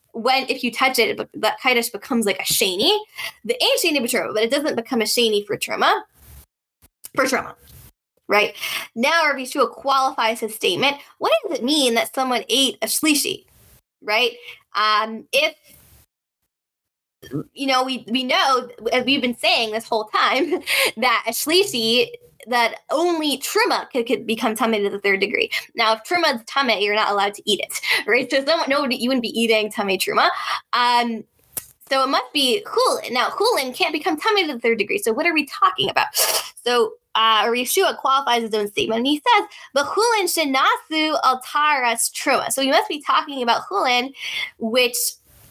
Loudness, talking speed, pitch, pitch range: -19 LUFS, 180 wpm, 260 Hz, 230-320 Hz